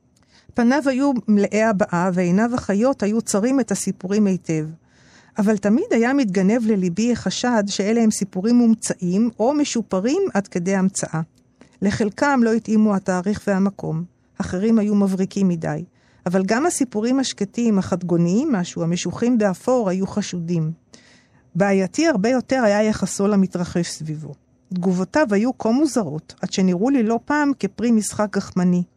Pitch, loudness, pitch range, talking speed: 200 Hz, -20 LUFS, 185-230 Hz, 135 wpm